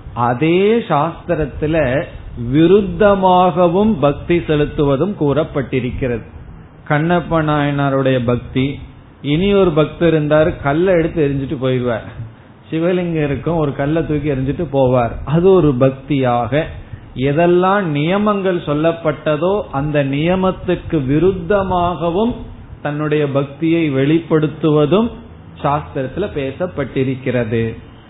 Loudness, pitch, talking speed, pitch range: -16 LUFS, 150 Hz, 75 wpm, 135-175 Hz